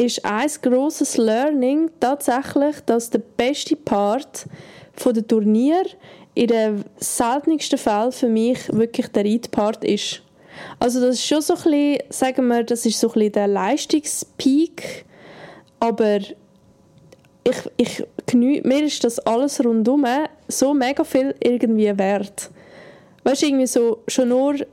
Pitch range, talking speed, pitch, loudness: 225-280 Hz, 140 wpm, 245 Hz, -20 LUFS